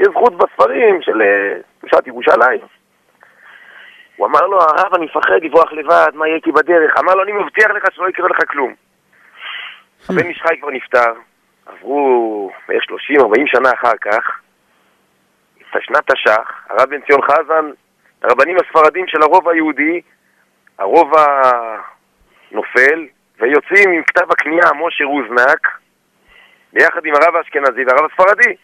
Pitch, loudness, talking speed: 185 Hz, -12 LUFS, 130 wpm